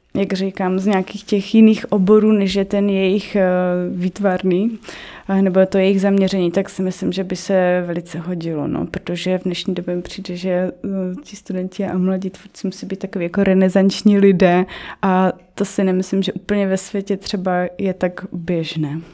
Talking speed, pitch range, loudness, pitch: 175 wpm, 180-195 Hz, -18 LUFS, 190 Hz